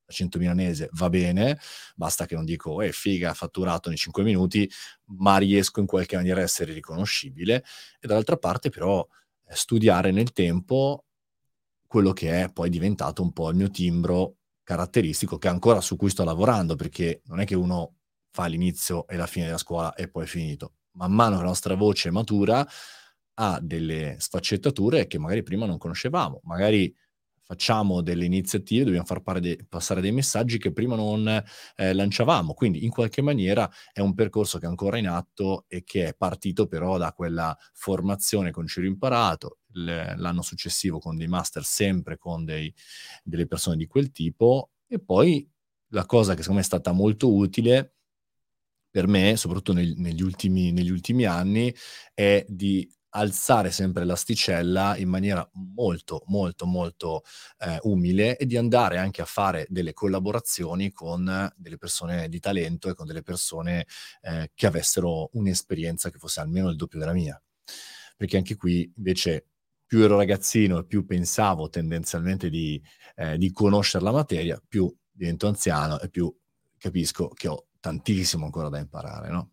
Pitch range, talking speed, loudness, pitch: 85-100 Hz, 165 wpm, -25 LUFS, 95 Hz